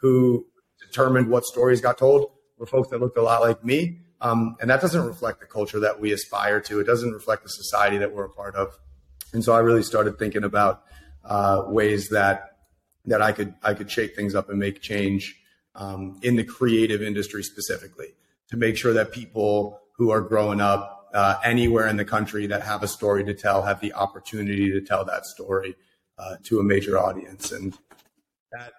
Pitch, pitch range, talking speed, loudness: 105 Hz, 100-115 Hz, 200 wpm, -23 LUFS